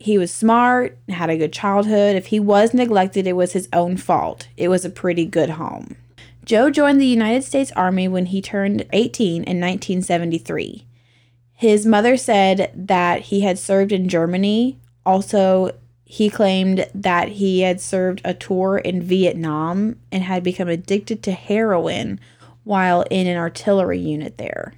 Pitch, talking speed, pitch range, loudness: 190 Hz, 160 wpm, 175-205 Hz, -18 LUFS